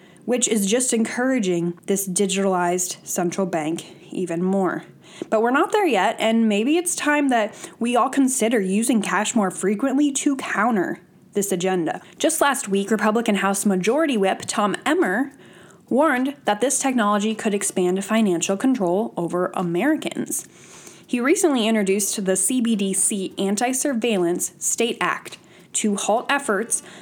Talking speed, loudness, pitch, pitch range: 140 wpm, -21 LUFS, 215 Hz, 190-255 Hz